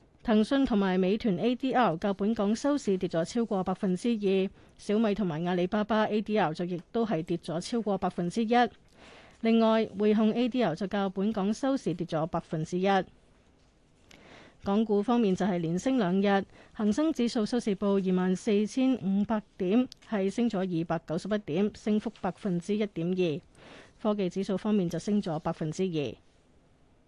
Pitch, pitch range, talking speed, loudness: 200 Hz, 180-220 Hz, 260 characters per minute, -29 LUFS